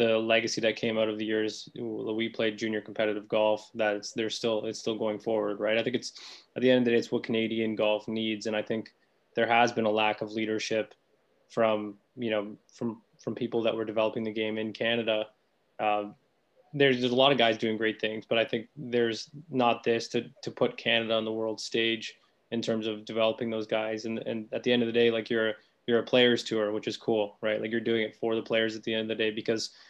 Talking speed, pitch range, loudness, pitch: 240 wpm, 110-115 Hz, -29 LUFS, 110 Hz